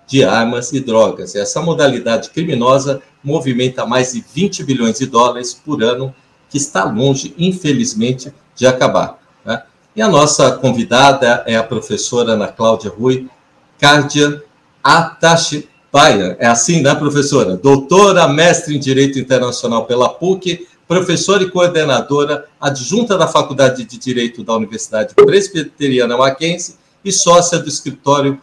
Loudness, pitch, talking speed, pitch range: -13 LUFS, 140 Hz, 130 wpm, 125-160 Hz